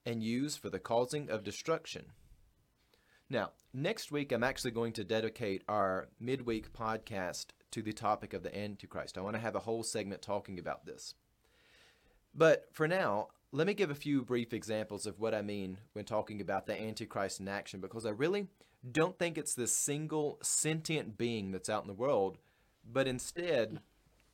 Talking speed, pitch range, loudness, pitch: 180 wpm, 105-135 Hz, -36 LUFS, 110 Hz